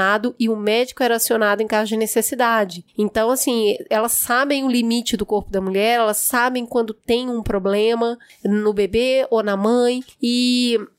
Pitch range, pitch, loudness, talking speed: 210-245 Hz, 230 Hz, -19 LUFS, 170 wpm